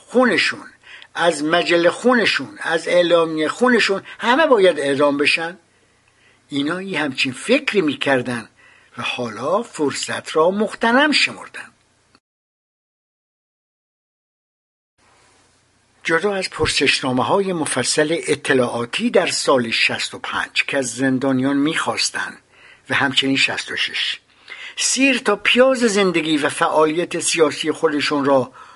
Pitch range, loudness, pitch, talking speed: 135-195 Hz, -18 LUFS, 160 Hz, 100 wpm